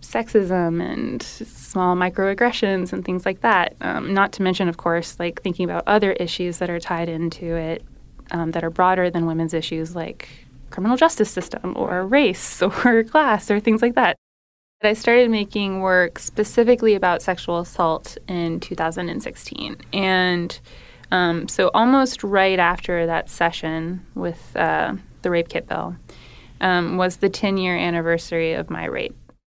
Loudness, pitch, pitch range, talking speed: -21 LUFS, 180 Hz, 170-205 Hz, 155 wpm